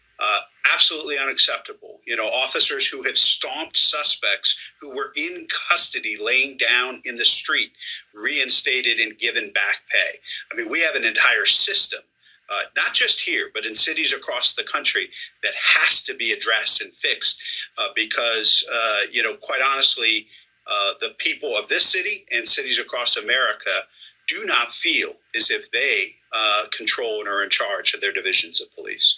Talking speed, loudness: 170 wpm, -17 LUFS